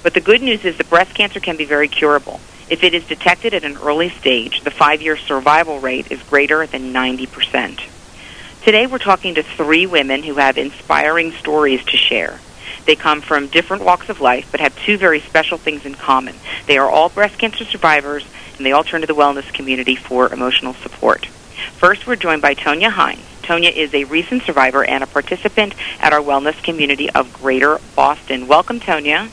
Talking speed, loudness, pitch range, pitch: 195 wpm, -14 LUFS, 140-175 Hz, 155 Hz